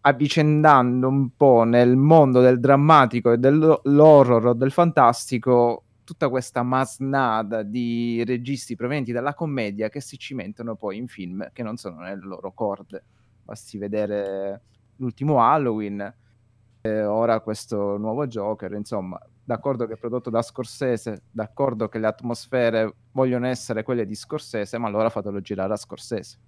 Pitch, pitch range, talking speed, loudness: 120 Hz, 110-130 Hz, 140 wpm, -21 LUFS